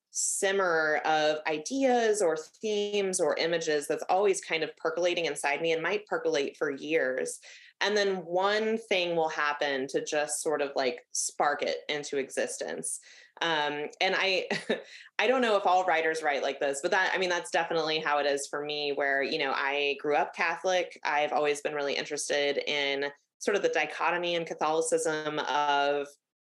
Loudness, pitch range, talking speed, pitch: -29 LUFS, 145-190 Hz, 175 wpm, 160 Hz